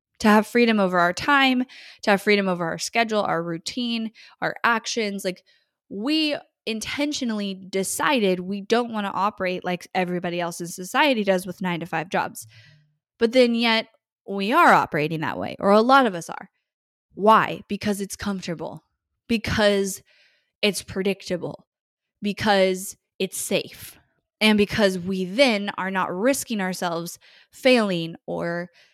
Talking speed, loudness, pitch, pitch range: 145 wpm, -22 LUFS, 200 Hz, 180-230 Hz